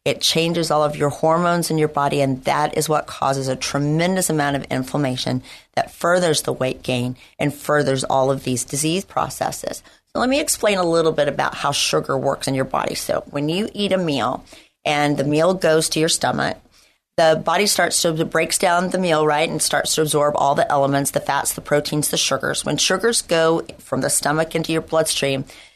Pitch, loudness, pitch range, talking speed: 155 Hz, -19 LUFS, 140-165 Hz, 205 wpm